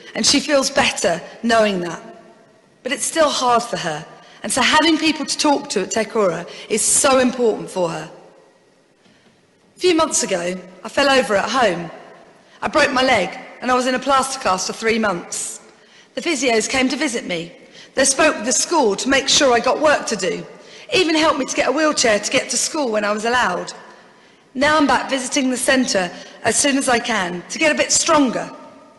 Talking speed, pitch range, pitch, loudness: 205 wpm, 220-290 Hz, 255 Hz, -17 LUFS